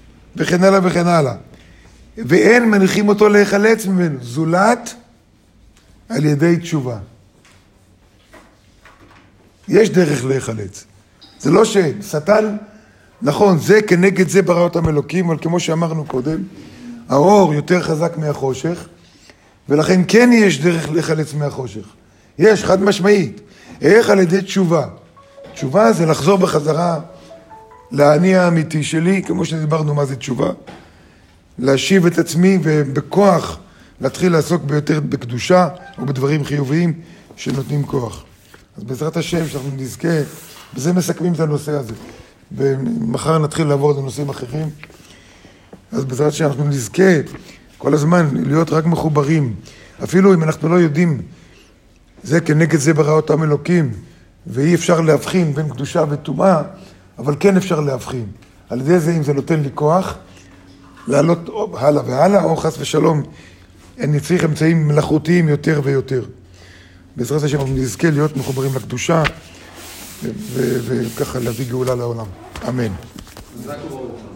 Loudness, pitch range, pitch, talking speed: -16 LUFS, 125-170 Hz, 150 Hz, 125 wpm